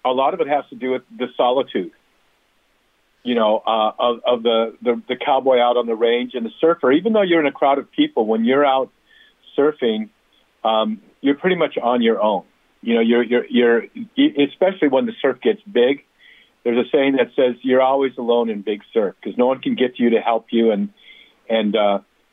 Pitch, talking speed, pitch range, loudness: 125 Hz, 215 wpm, 115-145 Hz, -19 LUFS